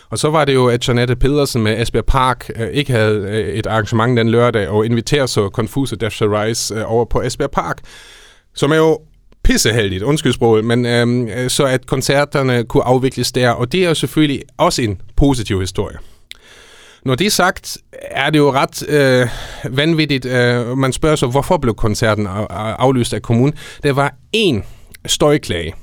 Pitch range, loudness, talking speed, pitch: 110-145 Hz, -15 LUFS, 175 wpm, 125 Hz